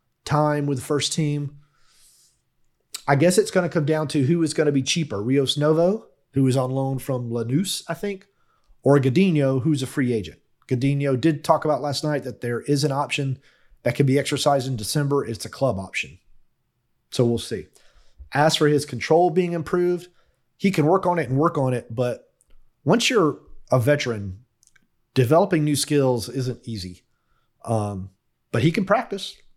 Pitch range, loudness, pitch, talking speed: 125-160 Hz, -22 LUFS, 140 Hz, 180 wpm